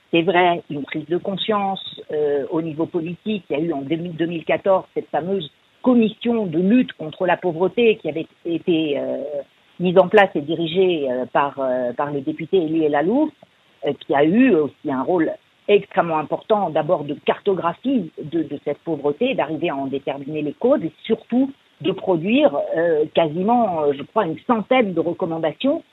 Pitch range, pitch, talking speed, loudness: 155-205 Hz, 170 Hz, 175 wpm, -20 LUFS